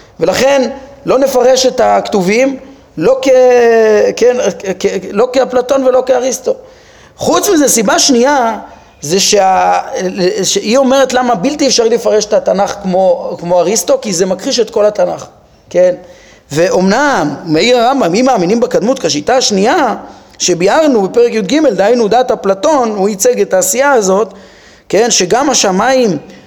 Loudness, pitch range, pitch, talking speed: -10 LUFS, 195-265 Hz, 235 Hz, 130 wpm